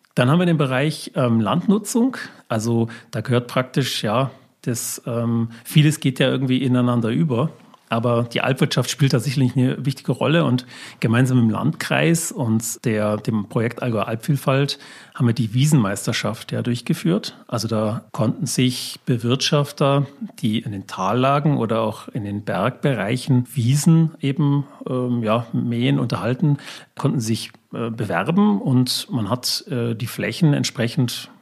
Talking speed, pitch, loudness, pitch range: 145 wpm, 125 Hz, -21 LUFS, 115-145 Hz